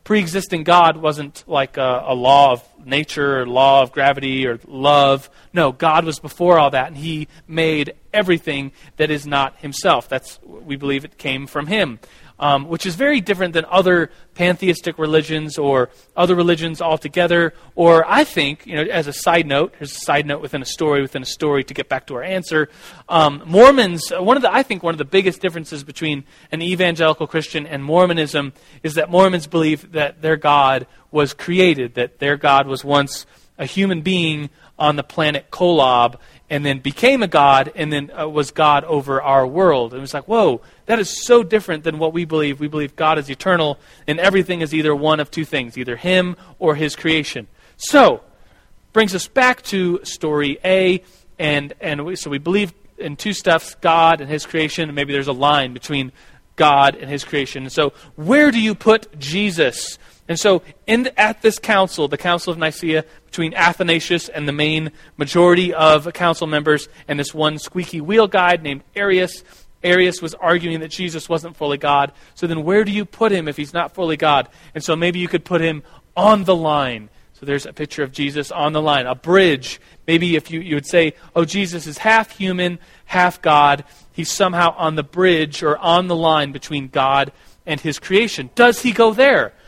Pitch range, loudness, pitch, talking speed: 145-175 Hz, -17 LUFS, 155 Hz, 195 wpm